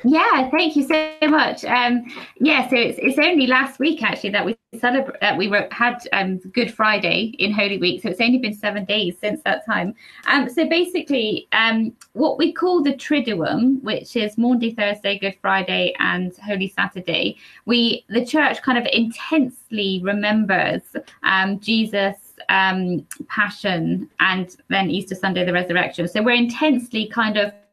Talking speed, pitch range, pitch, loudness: 165 wpm, 195-260 Hz, 225 Hz, -19 LUFS